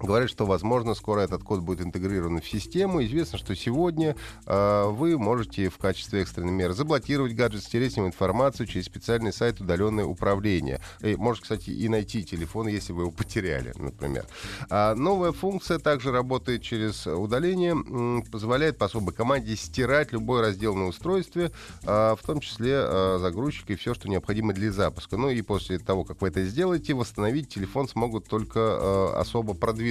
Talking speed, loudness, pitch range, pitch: 170 wpm, -27 LUFS, 95-125 Hz, 110 Hz